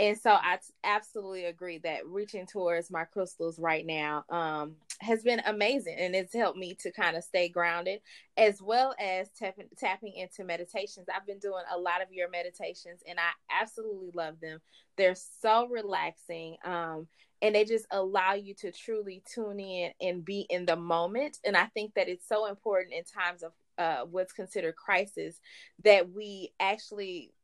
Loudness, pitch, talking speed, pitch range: -31 LUFS, 185 Hz, 175 wpm, 170-210 Hz